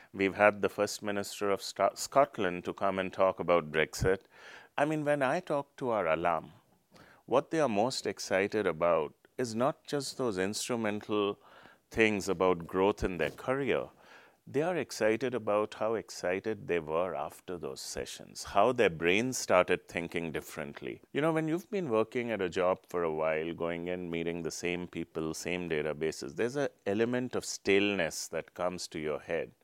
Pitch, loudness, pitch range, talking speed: 95 Hz, -32 LUFS, 85-110 Hz, 175 wpm